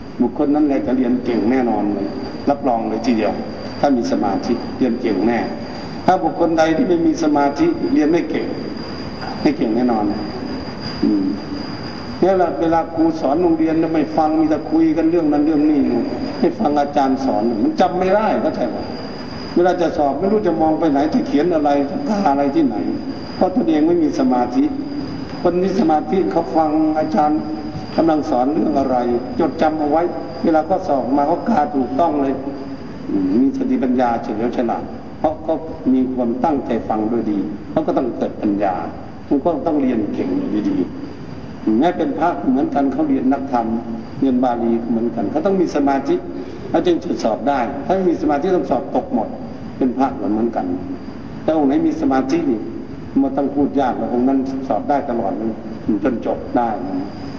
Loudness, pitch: -18 LUFS, 165 Hz